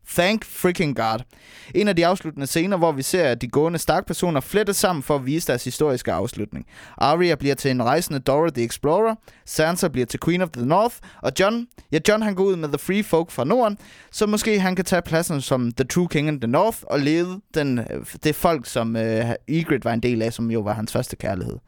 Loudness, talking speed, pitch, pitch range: -22 LUFS, 230 wpm, 155 Hz, 130-185 Hz